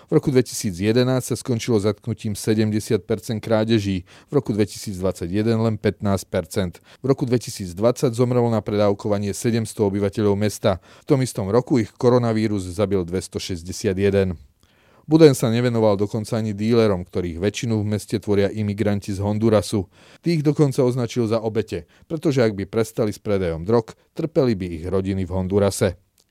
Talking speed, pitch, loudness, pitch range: 140 wpm, 110 Hz, -21 LUFS, 100-120 Hz